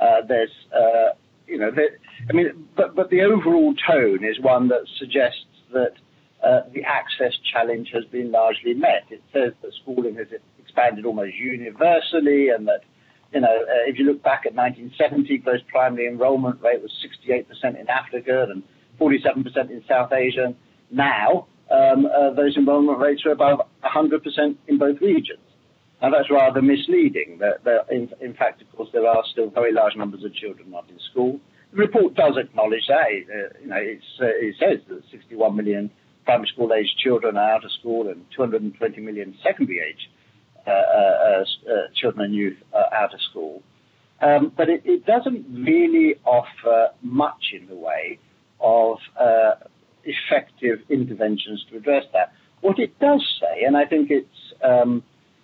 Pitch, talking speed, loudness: 140 Hz, 170 wpm, -20 LUFS